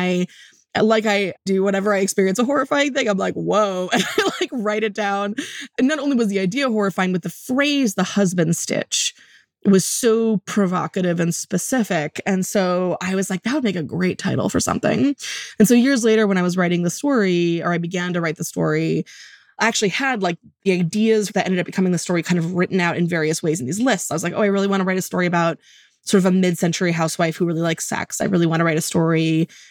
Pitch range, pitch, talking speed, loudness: 175-215 Hz, 190 Hz, 235 wpm, -20 LUFS